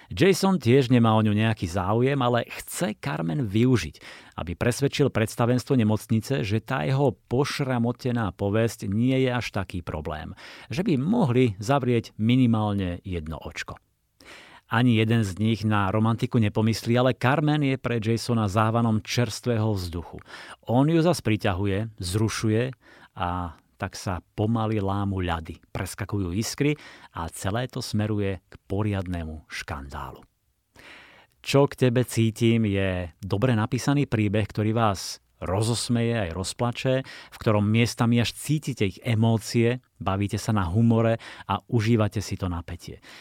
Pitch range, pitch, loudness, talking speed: 100-120 Hz, 110 Hz, -25 LUFS, 130 wpm